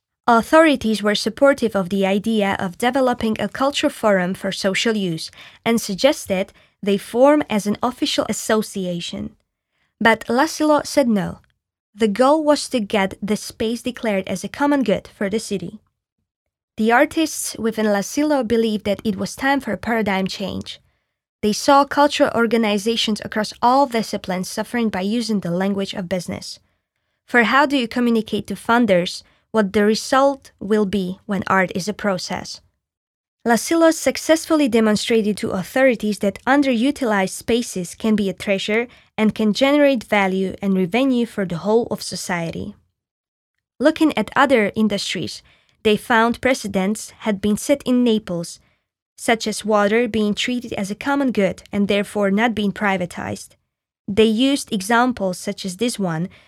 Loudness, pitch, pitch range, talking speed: -19 LUFS, 220 Hz, 200-250 Hz, 150 wpm